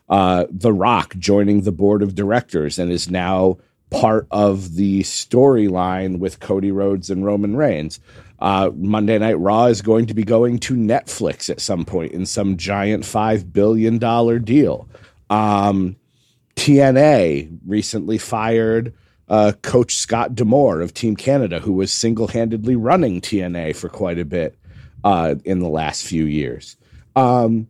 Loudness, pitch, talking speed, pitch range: -17 LUFS, 105 Hz, 150 wpm, 95-115 Hz